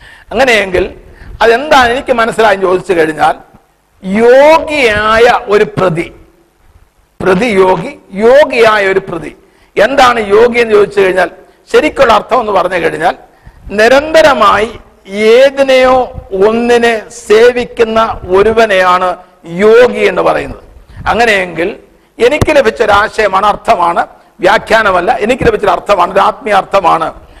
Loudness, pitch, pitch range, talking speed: -8 LUFS, 215 Hz, 190-240 Hz, 90 wpm